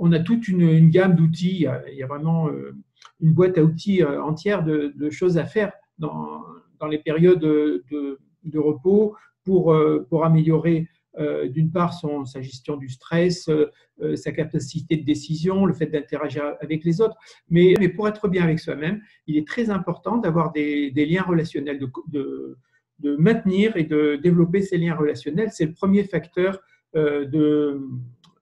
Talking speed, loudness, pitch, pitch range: 170 wpm, -21 LUFS, 160 Hz, 150-180 Hz